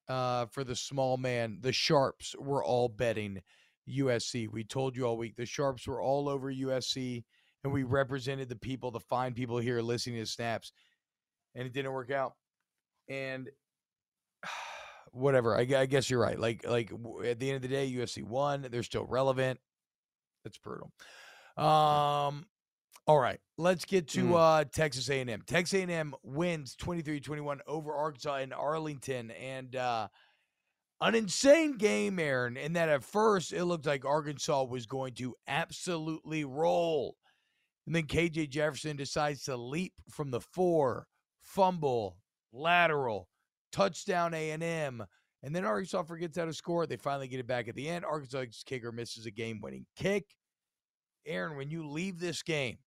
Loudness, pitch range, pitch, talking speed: -33 LUFS, 125-160 Hz, 140 Hz, 155 wpm